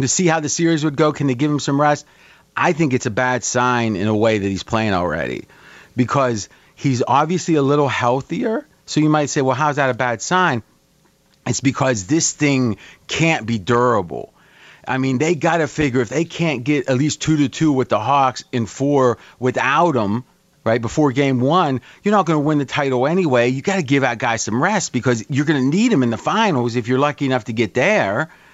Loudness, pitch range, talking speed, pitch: -18 LUFS, 125-150 Hz, 225 wpm, 135 Hz